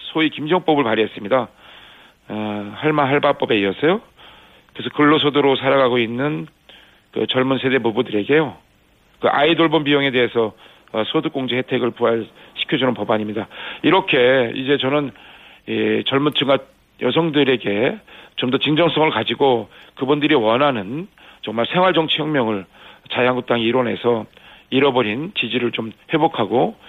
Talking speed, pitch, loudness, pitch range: 315 characters per minute, 130 Hz, -18 LUFS, 115-150 Hz